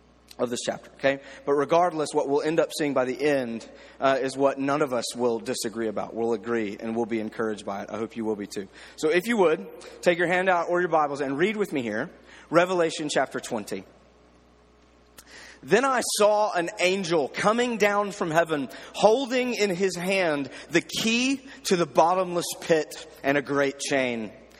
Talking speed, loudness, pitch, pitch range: 195 wpm, -25 LUFS, 145 Hz, 115-180 Hz